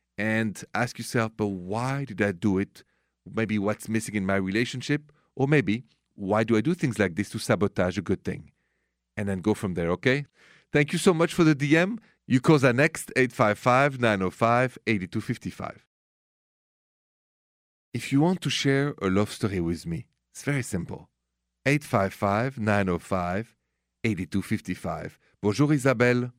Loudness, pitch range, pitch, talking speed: -26 LUFS, 100-135 Hz, 110 Hz, 145 wpm